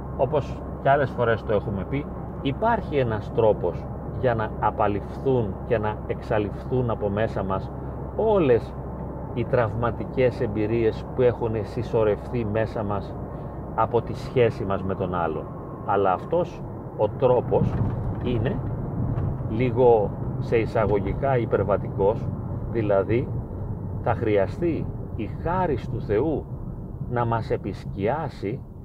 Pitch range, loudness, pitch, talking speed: 105-125 Hz, -25 LUFS, 115 Hz, 110 wpm